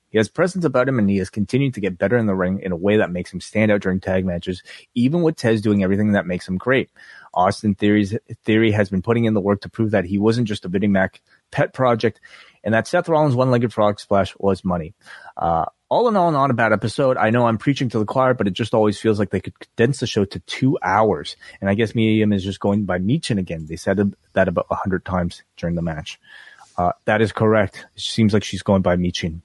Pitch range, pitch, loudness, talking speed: 95-115 Hz, 105 Hz, -20 LUFS, 255 wpm